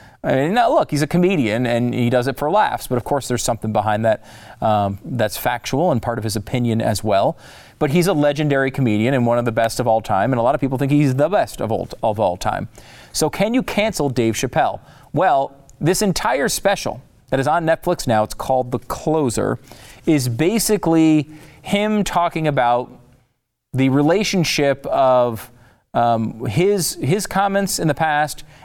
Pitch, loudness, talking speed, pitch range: 135 Hz, -19 LUFS, 180 wpm, 120-155 Hz